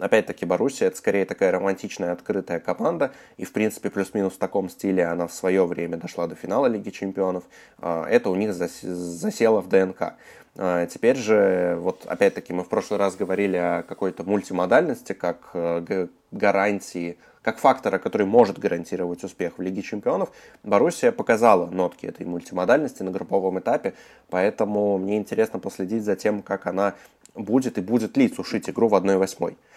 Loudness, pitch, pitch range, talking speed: -24 LUFS, 95 Hz, 90-105 Hz, 155 wpm